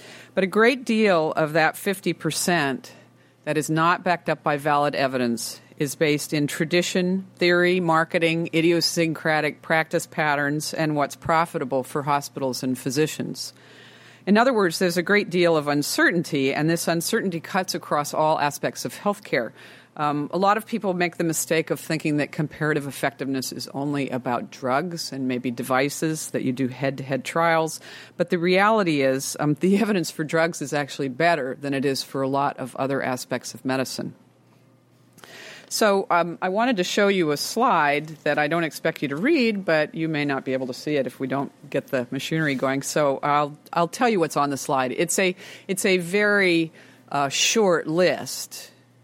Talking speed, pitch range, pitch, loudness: 185 wpm, 140-175 Hz, 155 Hz, -23 LUFS